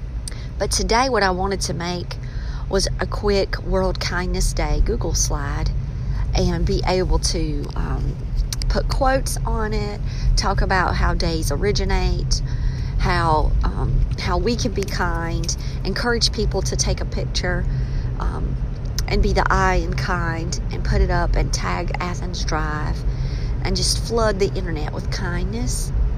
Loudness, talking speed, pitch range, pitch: -22 LUFS, 145 wpm, 130-195 Hz, 170 Hz